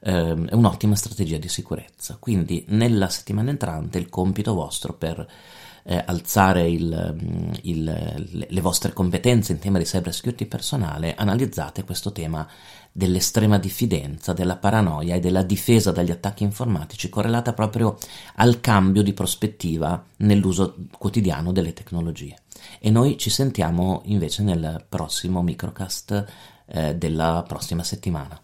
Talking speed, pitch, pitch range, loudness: 130 wpm, 95 Hz, 85-105 Hz, -23 LUFS